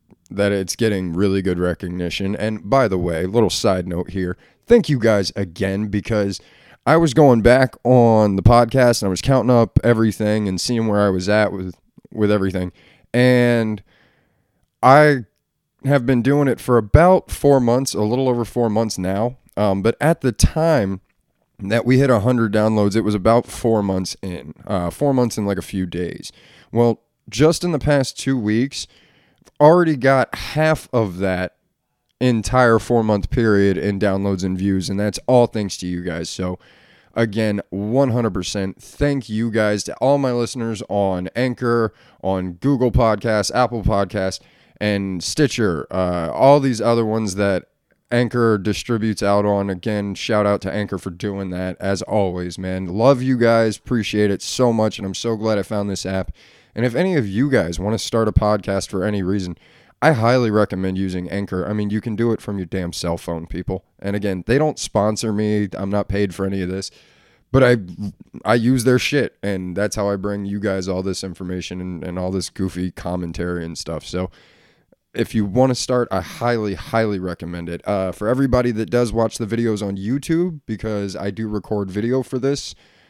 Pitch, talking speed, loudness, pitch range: 105 Hz, 190 wpm, -19 LUFS, 95-120 Hz